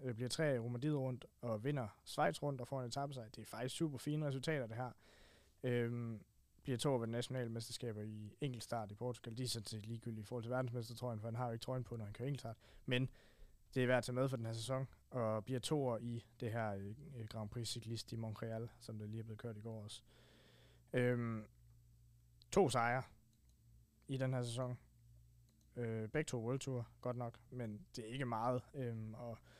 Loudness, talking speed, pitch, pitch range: -43 LUFS, 210 wpm, 120 Hz, 110-125 Hz